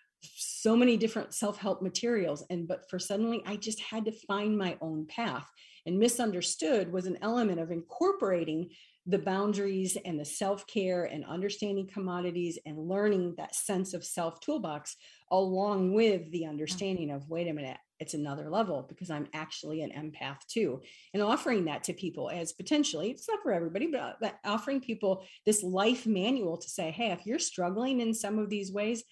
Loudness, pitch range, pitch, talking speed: -32 LUFS, 170-220 Hz, 190 Hz, 175 wpm